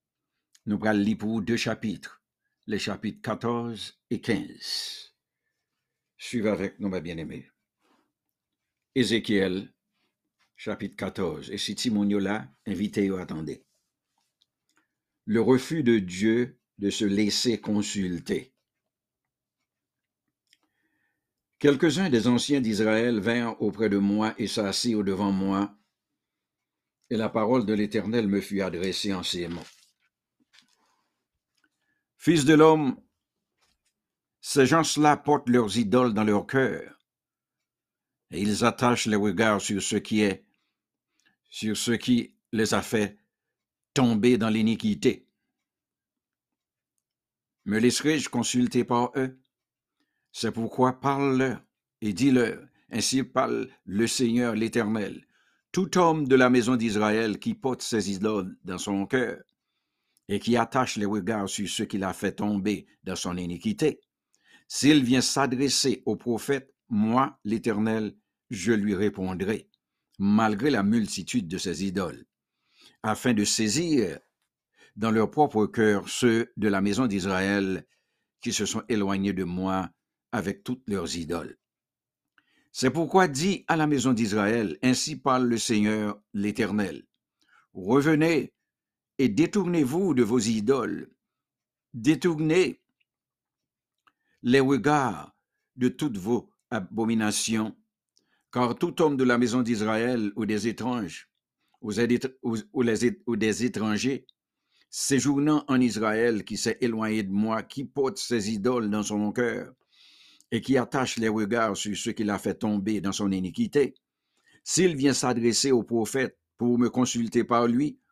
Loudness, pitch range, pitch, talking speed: -26 LUFS, 105-130 Hz, 115 Hz, 120 wpm